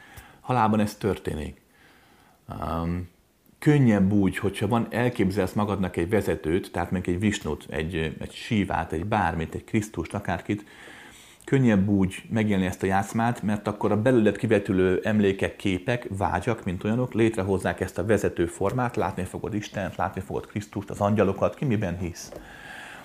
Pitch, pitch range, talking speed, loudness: 100 Hz, 90-110 Hz, 145 wpm, -26 LUFS